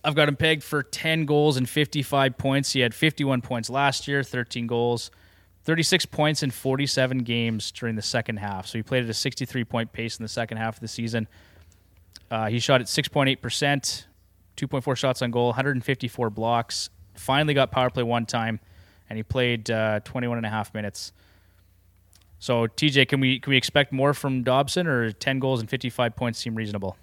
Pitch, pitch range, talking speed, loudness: 120 Hz, 110-135 Hz, 190 wpm, -24 LUFS